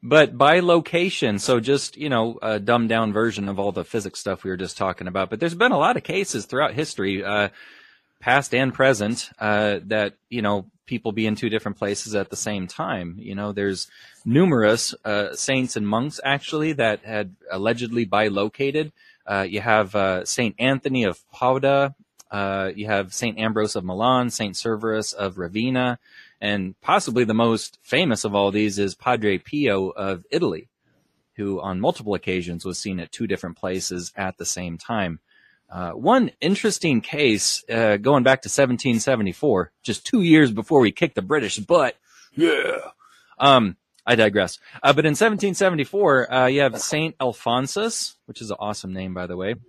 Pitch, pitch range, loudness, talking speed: 110 Hz, 100-135 Hz, -22 LUFS, 175 wpm